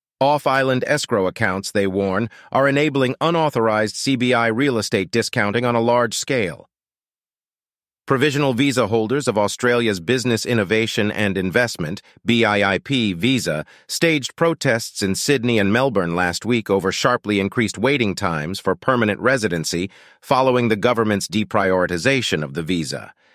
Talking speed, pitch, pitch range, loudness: 130 wpm, 115 Hz, 100-130 Hz, -19 LUFS